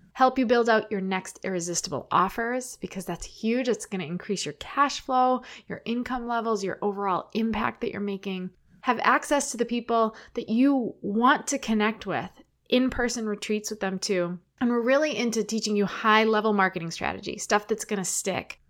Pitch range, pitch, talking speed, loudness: 195-245 Hz, 220 Hz, 185 wpm, -26 LUFS